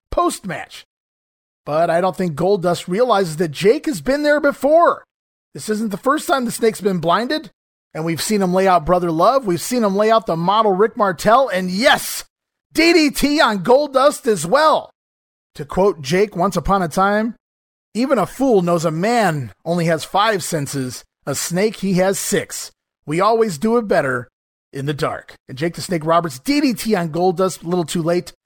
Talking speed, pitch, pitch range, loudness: 190 wpm, 190 Hz, 170-225 Hz, -17 LUFS